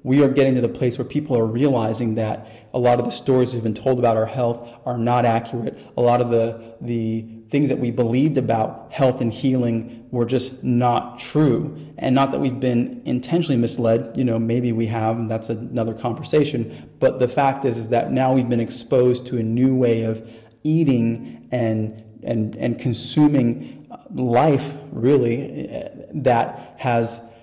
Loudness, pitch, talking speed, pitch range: -21 LUFS, 120 Hz, 180 wpm, 115-130 Hz